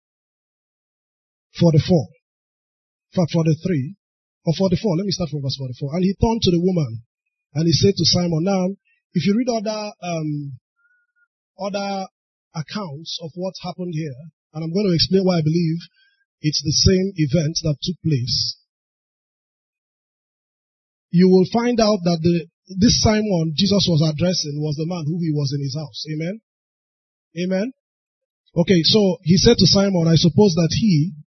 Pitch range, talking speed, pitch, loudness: 160-195 Hz, 170 wpm, 175 Hz, -19 LUFS